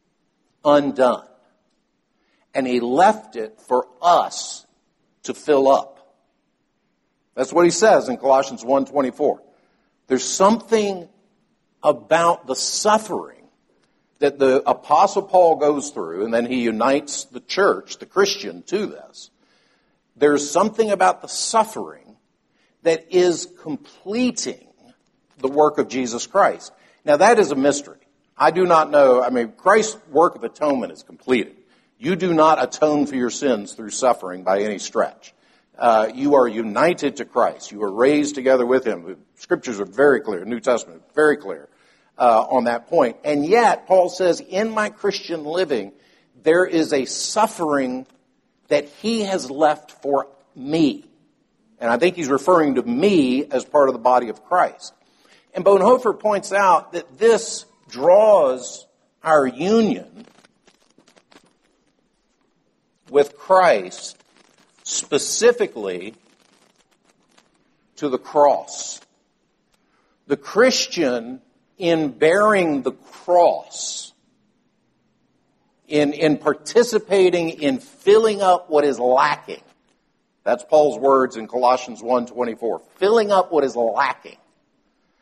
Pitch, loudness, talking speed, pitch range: 155 Hz, -19 LUFS, 125 wpm, 135-200 Hz